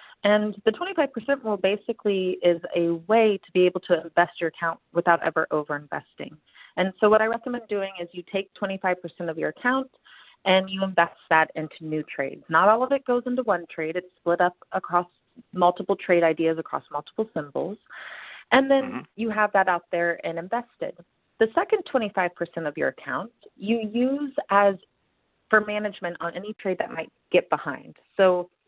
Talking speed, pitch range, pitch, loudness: 175 wpm, 170-220 Hz, 190 Hz, -24 LUFS